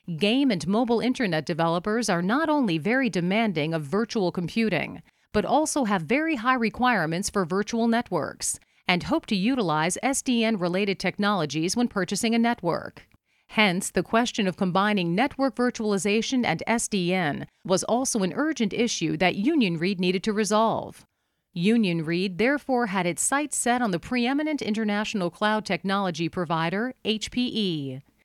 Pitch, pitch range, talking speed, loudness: 210 Hz, 180-240 Hz, 140 wpm, -25 LUFS